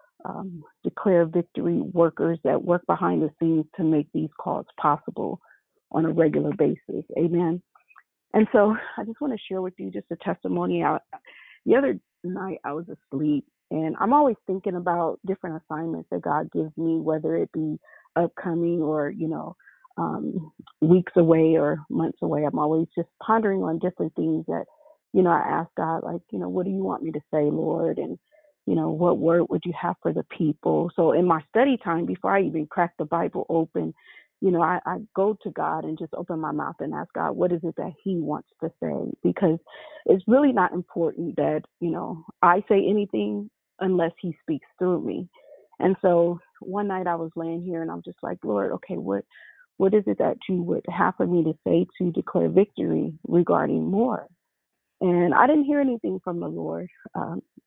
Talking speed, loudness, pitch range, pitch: 195 wpm, -25 LUFS, 160-195 Hz, 175 Hz